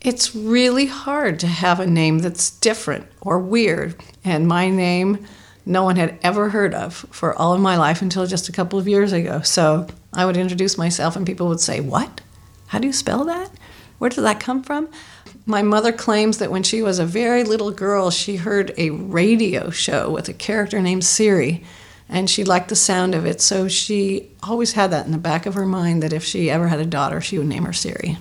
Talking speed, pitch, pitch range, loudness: 220 wpm, 190 Hz, 175-215 Hz, -19 LUFS